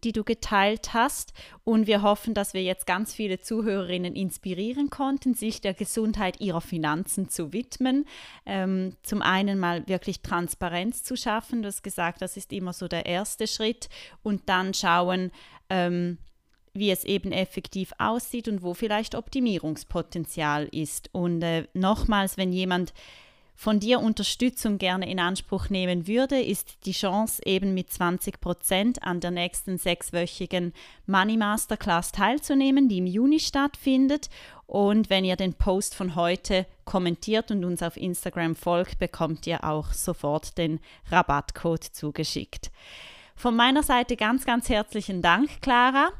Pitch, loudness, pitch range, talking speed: 190 Hz, -26 LUFS, 180-220 Hz, 145 wpm